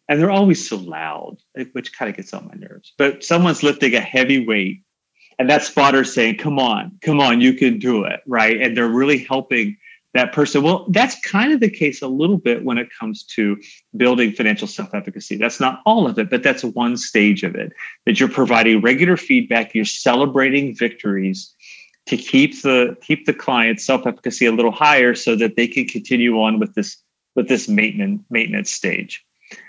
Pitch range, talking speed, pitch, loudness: 115-160 Hz, 190 wpm, 130 Hz, -17 LUFS